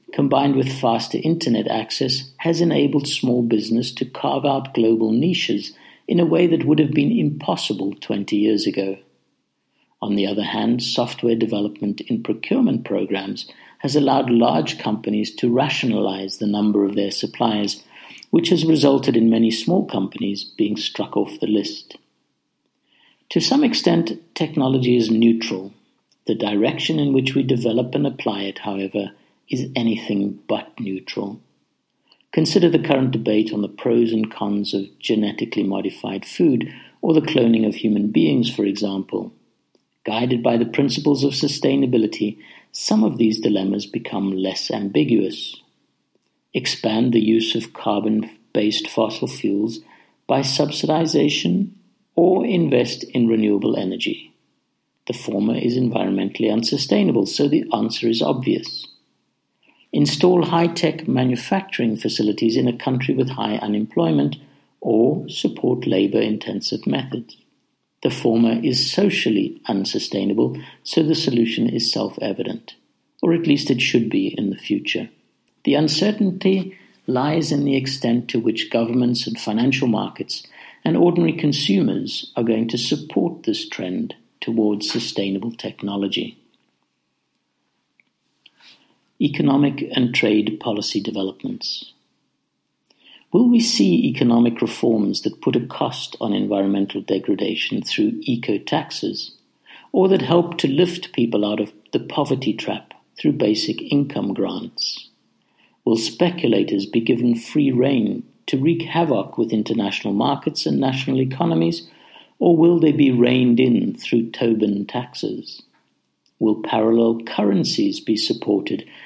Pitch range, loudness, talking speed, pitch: 105-145 Hz, -20 LUFS, 130 wpm, 120 Hz